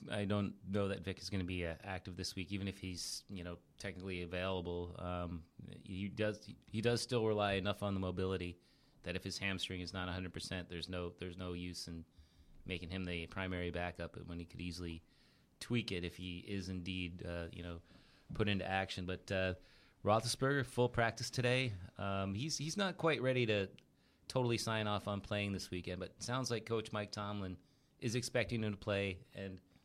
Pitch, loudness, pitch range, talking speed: 95 Hz, -40 LUFS, 90-105 Hz, 200 wpm